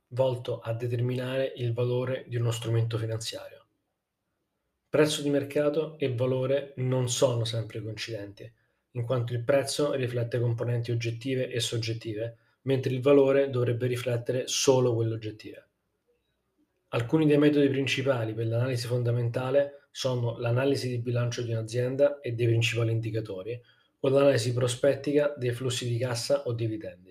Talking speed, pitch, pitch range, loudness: 135 wpm, 125 Hz, 115-135 Hz, -28 LUFS